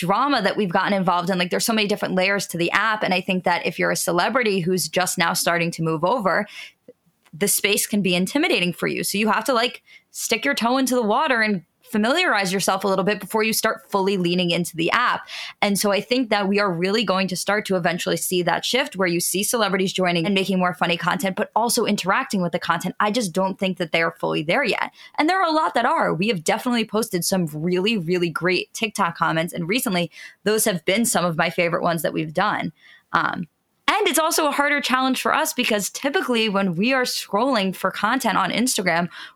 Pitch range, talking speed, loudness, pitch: 180-225 Hz, 235 wpm, -21 LUFS, 195 Hz